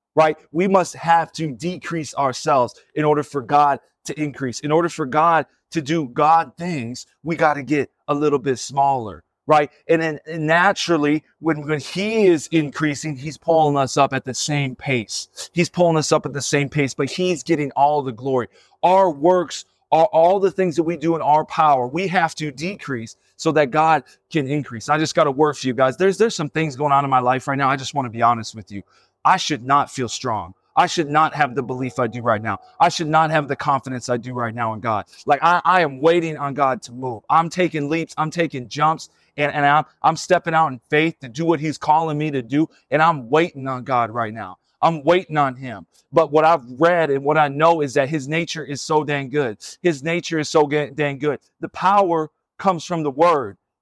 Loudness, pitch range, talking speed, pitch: -19 LUFS, 135-165 Hz, 230 wpm, 150 Hz